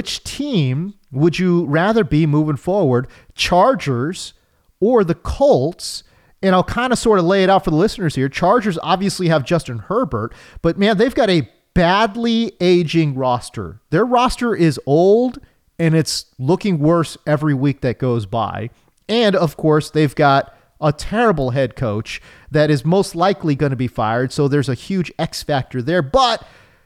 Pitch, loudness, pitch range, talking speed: 160 Hz, -17 LUFS, 135-190 Hz, 170 wpm